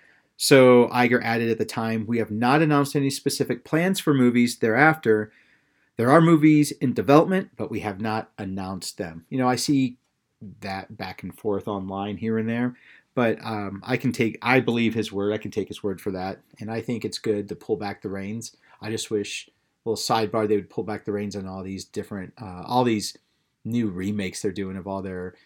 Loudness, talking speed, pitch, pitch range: -23 LUFS, 215 wpm, 110 Hz, 100-125 Hz